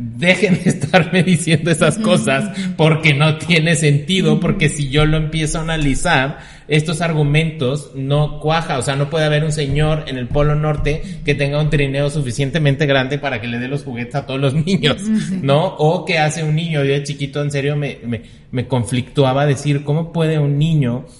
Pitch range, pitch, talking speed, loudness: 140-160 Hz, 150 Hz, 190 wpm, -17 LUFS